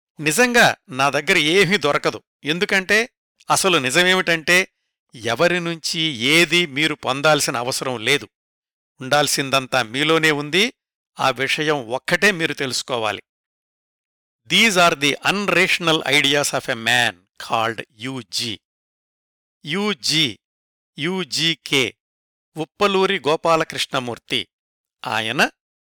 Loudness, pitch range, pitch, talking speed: -18 LUFS, 130-175 Hz, 155 Hz, 90 wpm